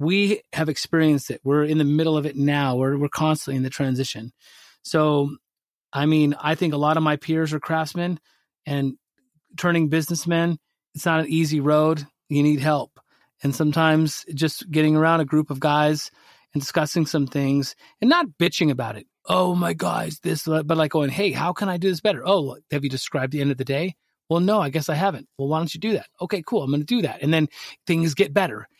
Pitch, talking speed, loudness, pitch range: 155 Hz, 220 wpm, -22 LUFS, 145-170 Hz